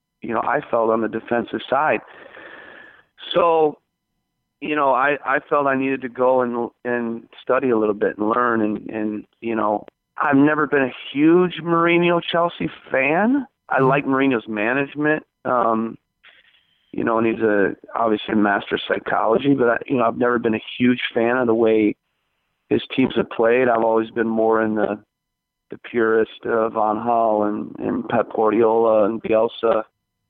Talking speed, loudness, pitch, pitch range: 170 wpm, -20 LUFS, 115 Hz, 110-135 Hz